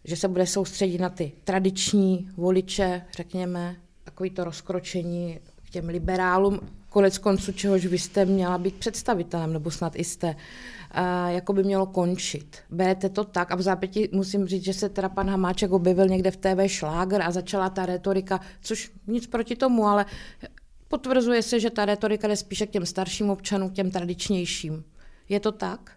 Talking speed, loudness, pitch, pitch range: 170 wpm, -26 LUFS, 190 Hz, 180-200 Hz